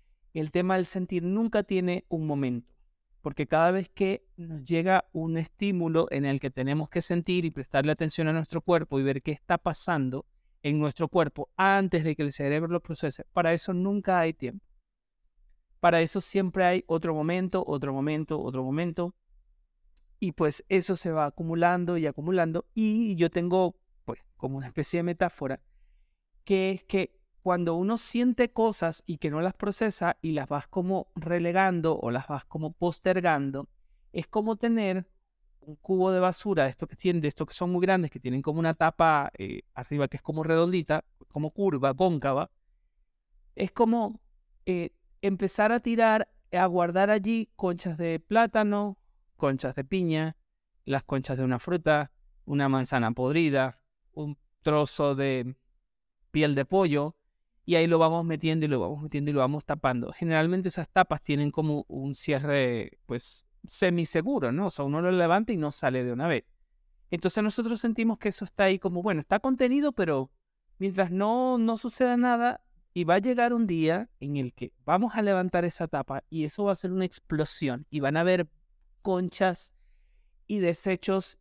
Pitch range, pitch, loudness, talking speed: 145-190 Hz, 165 Hz, -28 LUFS, 175 wpm